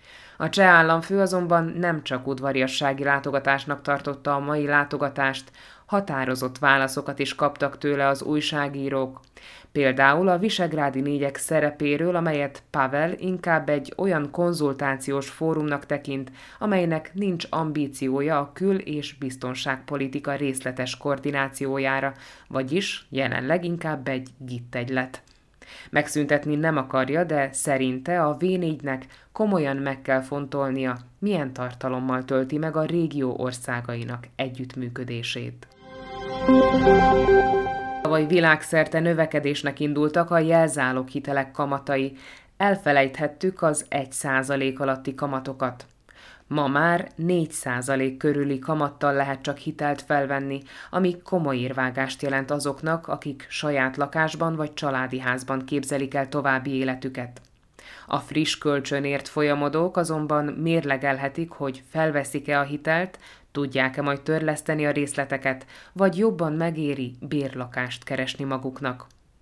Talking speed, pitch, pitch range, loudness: 105 wpm, 140 Hz, 135-155 Hz, -24 LUFS